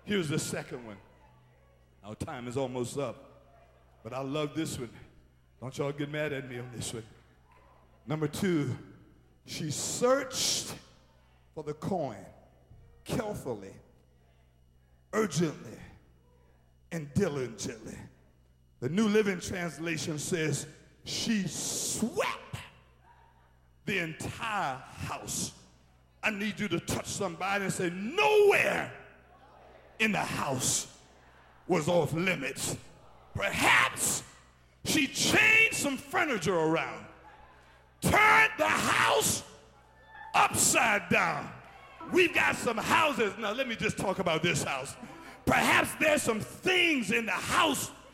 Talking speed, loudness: 110 wpm, -29 LUFS